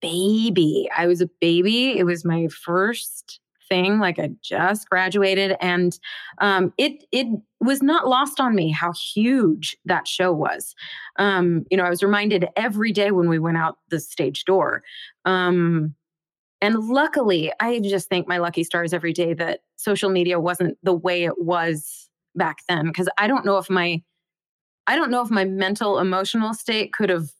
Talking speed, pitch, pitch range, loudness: 175 wpm, 185 Hz, 170-205 Hz, -21 LUFS